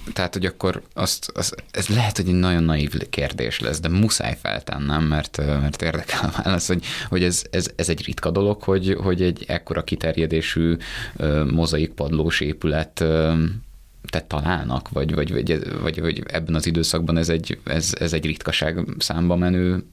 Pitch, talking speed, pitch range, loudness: 80 Hz, 160 wpm, 80-90 Hz, -22 LUFS